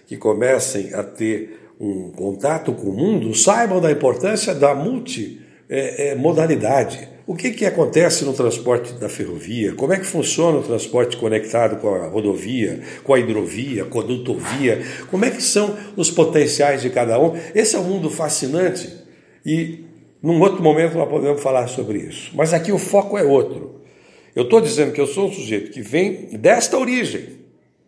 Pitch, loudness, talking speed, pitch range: 155 Hz, -18 LUFS, 175 wpm, 125-185 Hz